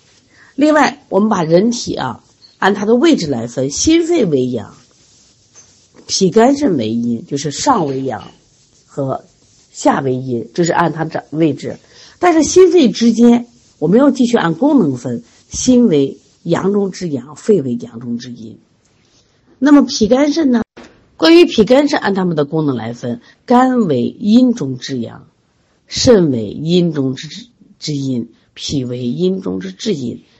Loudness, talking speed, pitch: -14 LUFS, 215 characters per minute, 170 Hz